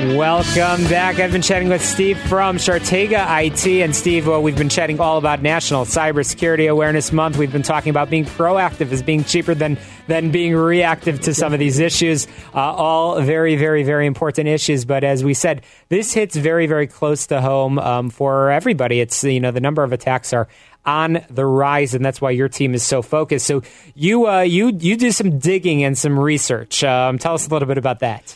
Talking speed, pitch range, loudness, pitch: 210 wpm, 140-170 Hz, -17 LUFS, 155 Hz